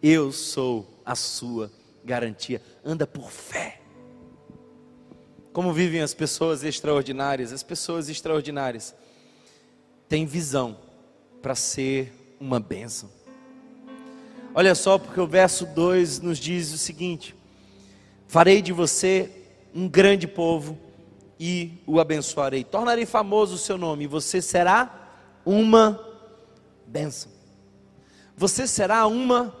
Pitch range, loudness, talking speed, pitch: 130-185 Hz, -23 LUFS, 110 wpm, 160 Hz